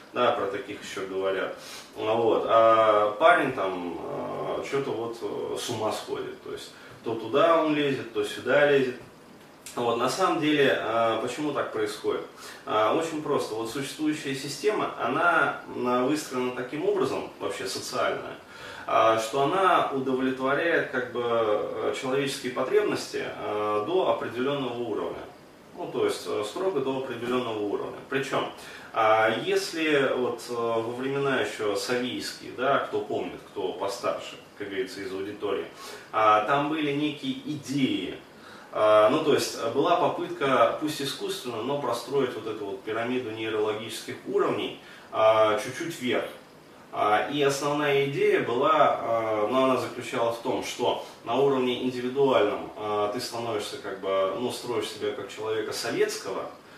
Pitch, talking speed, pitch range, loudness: 130 Hz, 125 wpm, 115-165 Hz, -27 LUFS